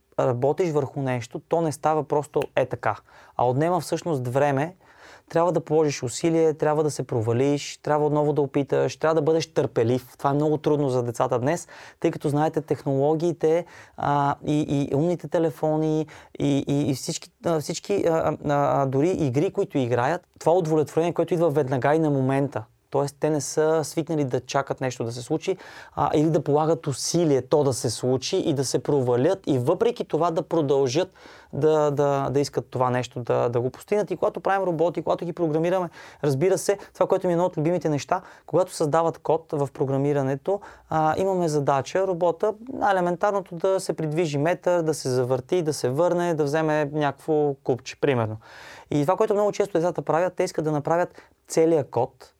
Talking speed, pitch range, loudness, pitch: 185 wpm, 140-170 Hz, -24 LUFS, 155 Hz